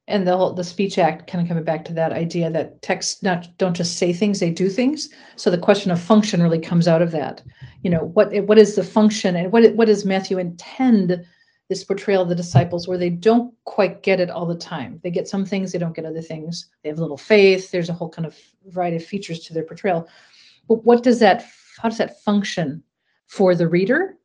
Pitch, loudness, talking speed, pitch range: 185 Hz, -19 LUFS, 235 wpm, 170-210 Hz